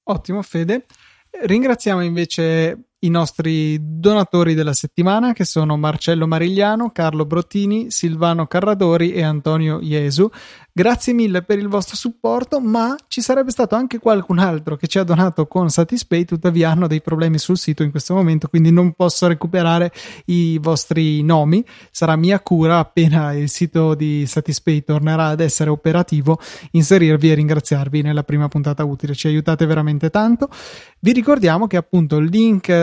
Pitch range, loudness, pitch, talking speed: 155-200 Hz, -17 LUFS, 170 Hz, 155 wpm